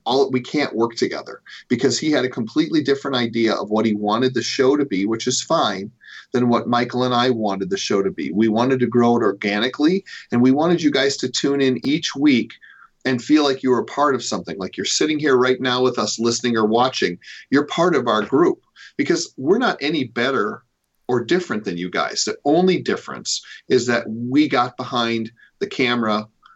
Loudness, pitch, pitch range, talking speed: -19 LUFS, 125 Hz, 115-140 Hz, 210 wpm